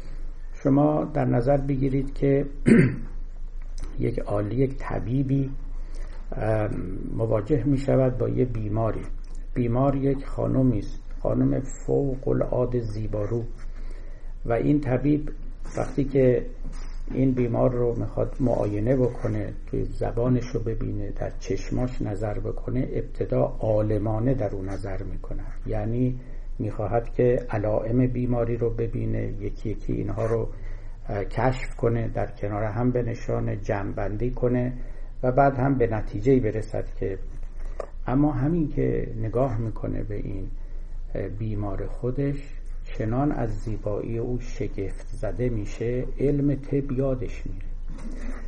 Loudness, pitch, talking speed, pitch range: -26 LUFS, 120 Hz, 120 wpm, 105-130 Hz